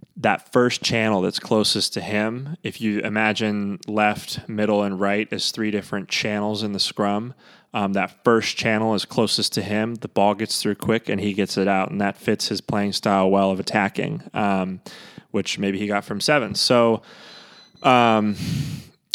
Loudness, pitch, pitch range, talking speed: -22 LUFS, 105 Hz, 100-110 Hz, 180 wpm